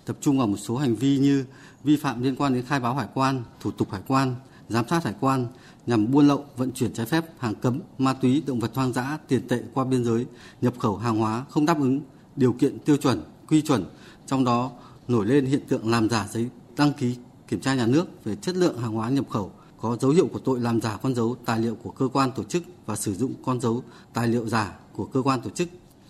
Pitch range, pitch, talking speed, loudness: 115-140 Hz, 130 Hz, 250 wpm, -25 LUFS